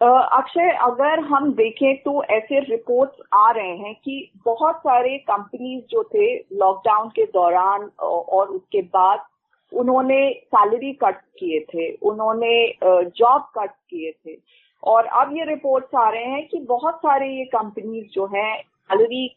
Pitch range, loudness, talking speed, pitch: 210-285 Hz, -19 LUFS, 145 wpm, 250 Hz